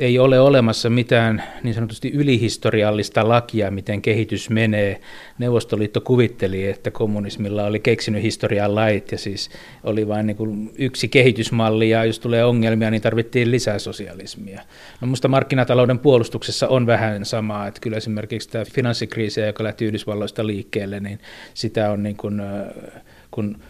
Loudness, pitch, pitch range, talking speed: -20 LUFS, 110 Hz, 105-120 Hz, 140 wpm